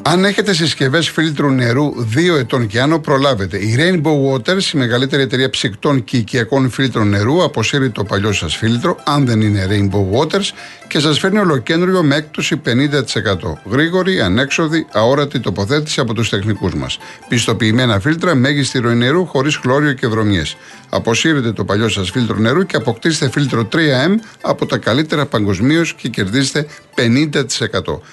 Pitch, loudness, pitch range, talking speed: 135 Hz, -15 LUFS, 115-155 Hz, 155 wpm